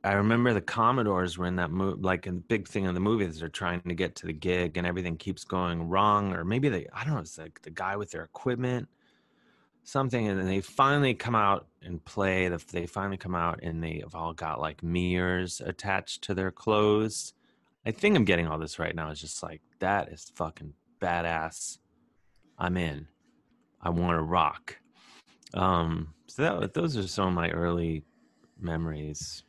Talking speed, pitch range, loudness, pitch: 195 wpm, 85-100 Hz, -29 LUFS, 90 Hz